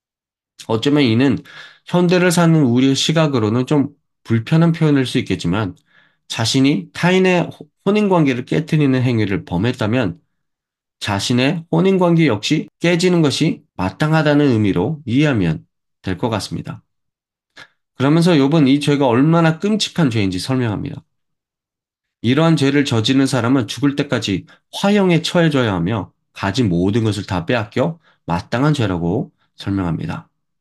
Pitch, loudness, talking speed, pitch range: 135 Hz, -17 LUFS, 300 characters per minute, 110-155 Hz